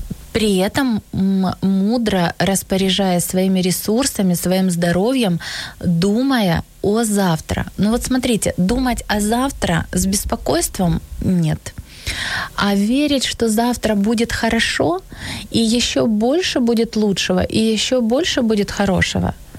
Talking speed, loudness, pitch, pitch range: 110 wpm, -17 LUFS, 205 Hz, 185-235 Hz